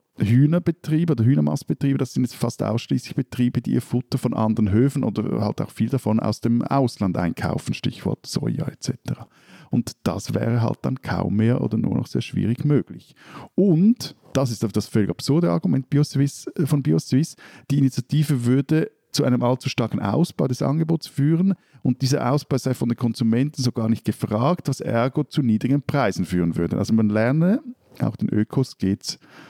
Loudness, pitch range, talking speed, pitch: -22 LUFS, 115-145 Hz, 175 wpm, 130 Hz